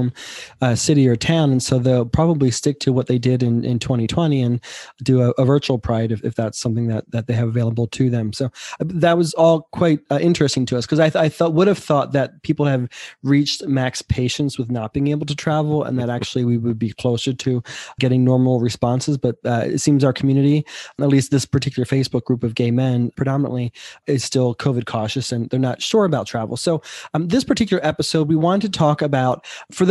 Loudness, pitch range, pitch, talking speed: -19 LUFS, 120-150 Hz, 130 Hz, 225 wpm